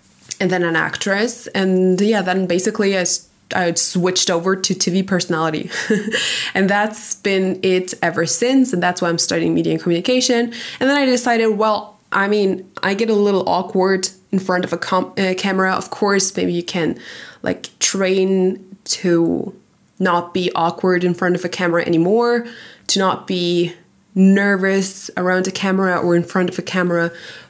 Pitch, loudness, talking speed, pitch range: 190 Hz, -16 LUFS, 170 wpm, 175-200 Hz